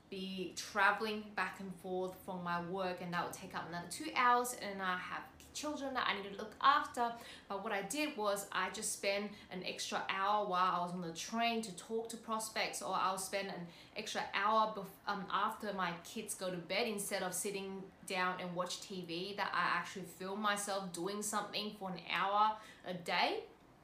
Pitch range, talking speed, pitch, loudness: 185-215 Hz, 200 wpm, 195 Hz, -38 LUFS